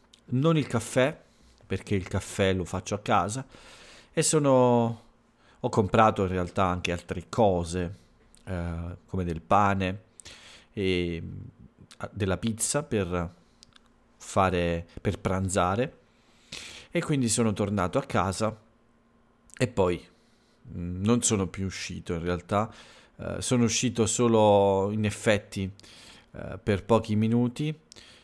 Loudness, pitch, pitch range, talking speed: -27 LUFS, 105 Hz, 95-115 Hz, 115 wpm